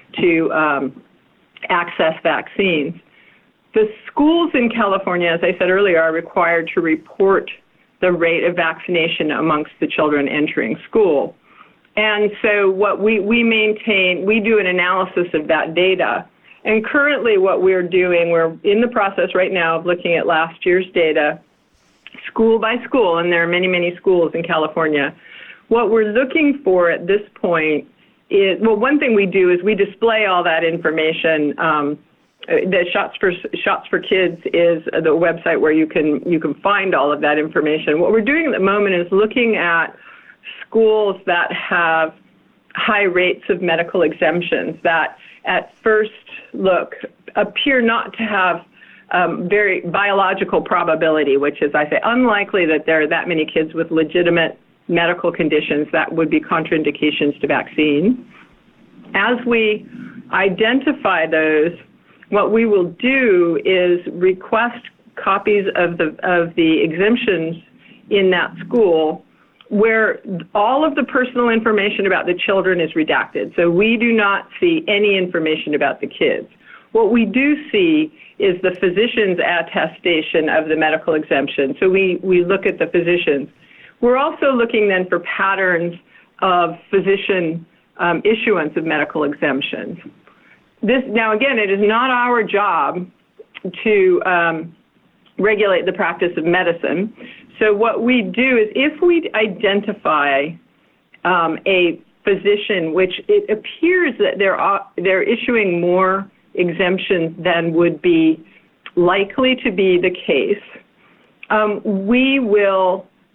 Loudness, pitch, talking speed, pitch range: -16 LUFS, 190 Hz, 145 wpm, 170-225 Hz